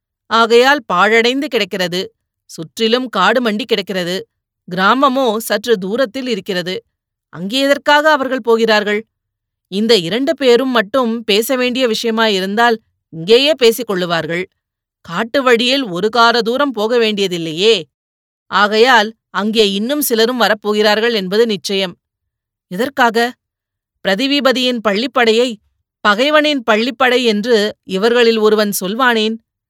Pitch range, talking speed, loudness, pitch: 200-245 Hz, 95 wpm, -14 LUFS, 225 Hz